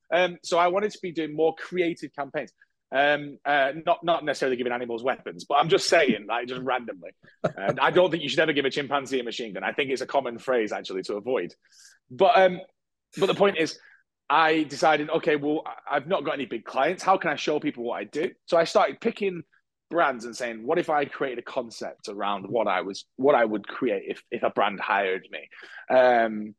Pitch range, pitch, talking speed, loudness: 125-170 Hz, 150 Hz, 225 wpm, -25 LUFS